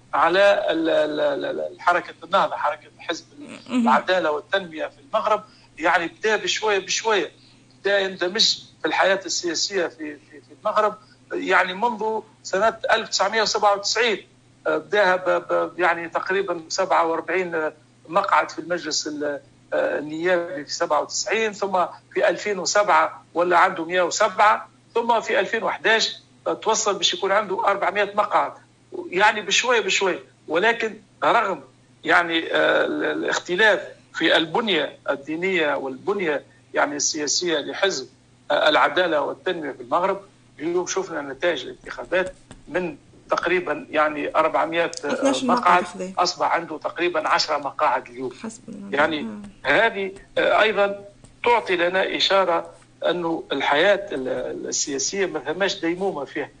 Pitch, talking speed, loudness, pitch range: 180 Hz, 105 wpm, -22 LUFS, 160-210 Hz